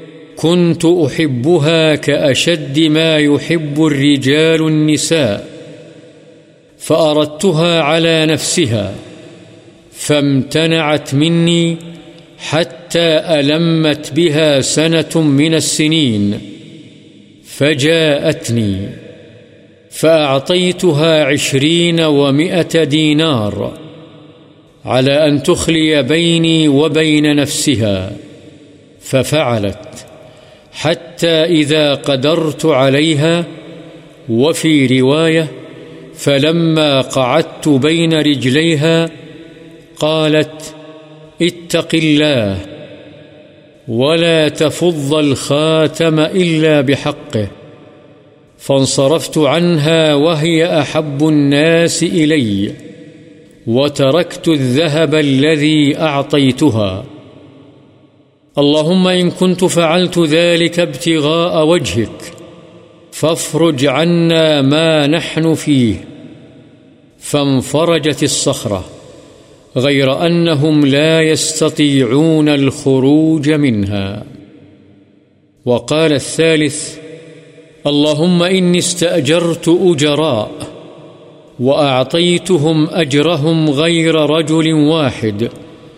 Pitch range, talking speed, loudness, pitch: 145-160 Hz, 60 wpm, -12 LUFS, 155 Hz